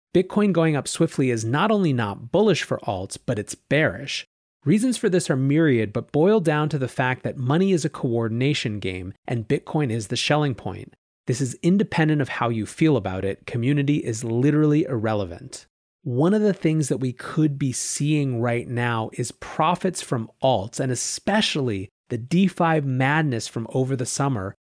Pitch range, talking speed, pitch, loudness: 120-160 Hz, 180 wpm, 135 Hz, -23 LUFS